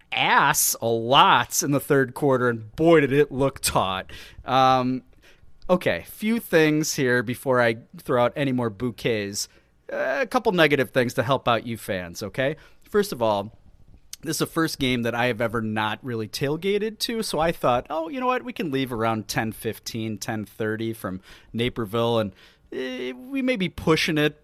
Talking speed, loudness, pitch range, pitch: 185 wpm, -23 LUFS, 115-160 Hz, 130 Hz